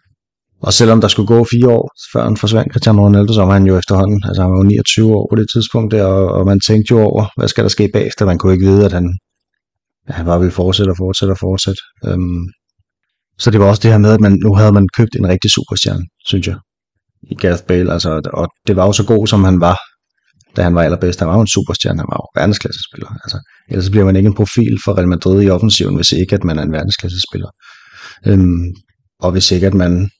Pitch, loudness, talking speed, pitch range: 100 Hz, -12 LUFS, 245 wpm, 95-110 Hz